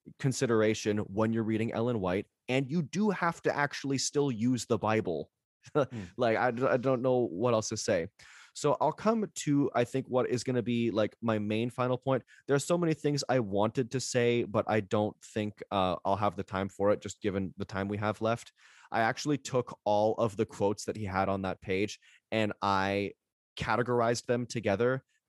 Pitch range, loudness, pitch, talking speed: 105-130 Hz, -31 LUFS, 115 Hz, 205 wpm